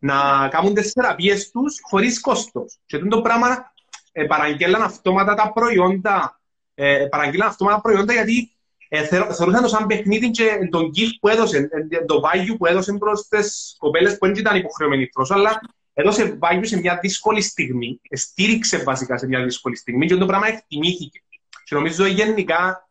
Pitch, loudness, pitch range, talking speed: 195 Hz, -19 LUFS, 165-215 Hz, 175 wpm